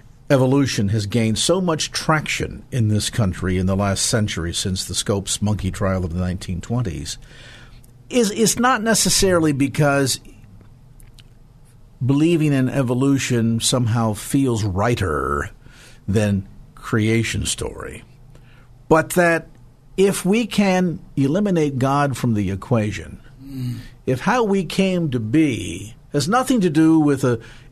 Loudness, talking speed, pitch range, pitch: -19 LUFS, 125 wpm, 110-150 Hz, 125 Hz